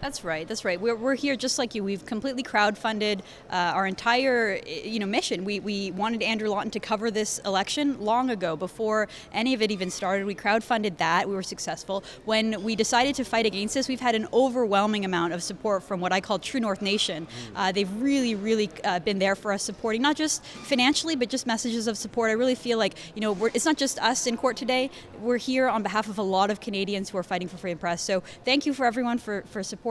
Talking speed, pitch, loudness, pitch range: 240 wpm, 215 Hz, -26 LUFS, 195-245 Hz